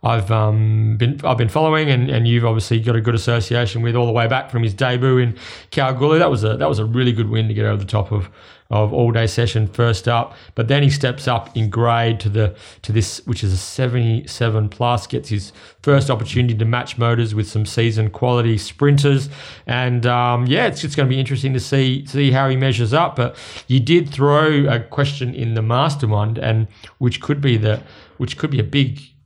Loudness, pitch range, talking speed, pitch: -18 LUFS, 110-135 Hz, 220 wpm, 120 Hz